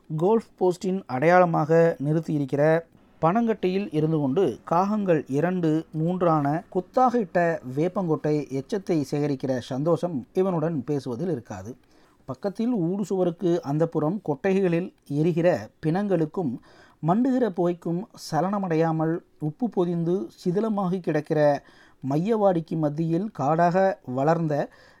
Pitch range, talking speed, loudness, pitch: 155-185 Hz, 90 wpm, -25 LUFS, 165 Hz